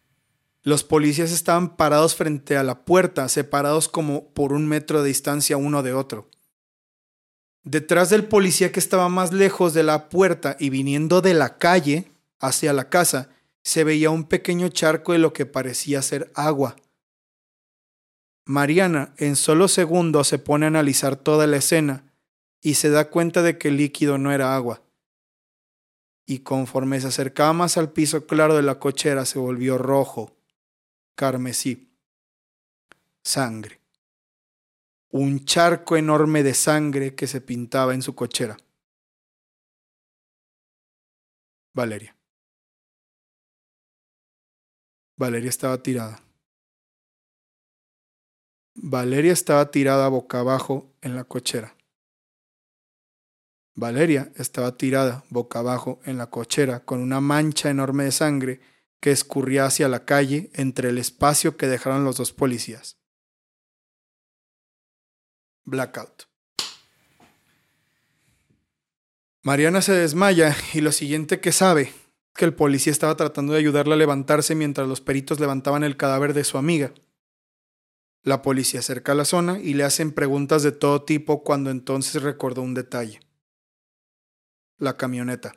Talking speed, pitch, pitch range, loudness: 130 wpm, 145 Hz, 130-155 Hz, -21 LUFS